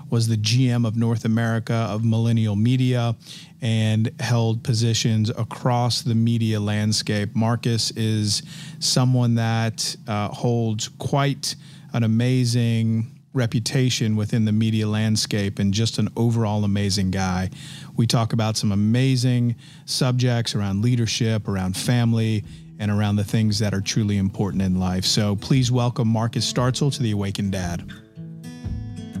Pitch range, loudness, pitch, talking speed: 105-125 Hz, -22 LUFS, 115 Hz, 135 wpm